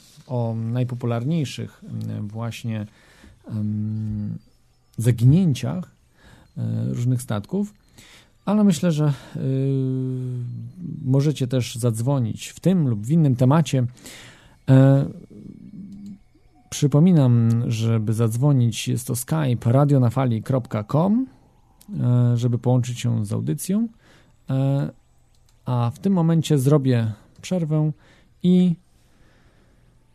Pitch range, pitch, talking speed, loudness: 115-155 Hz, 130 Hz, 75 wpm, -22 LUFS